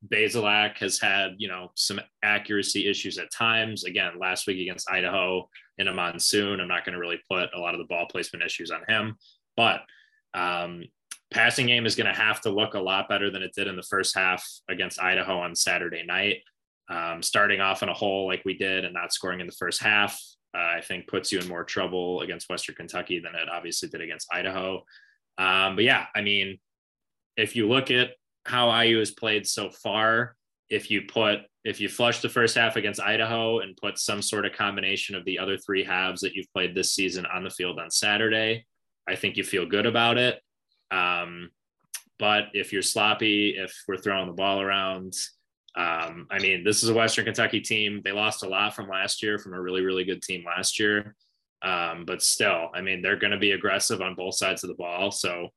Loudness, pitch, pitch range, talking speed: -25 LUFS, 100 Hz, 90-105 Hz, 215 wpm